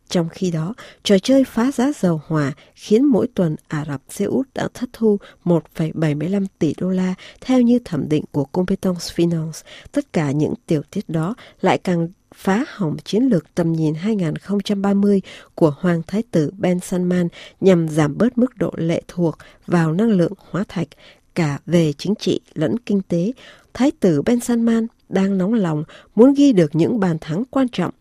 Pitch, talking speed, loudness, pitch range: 185 Hz, 180 wpm, -19 LUFS, 165-220 Hz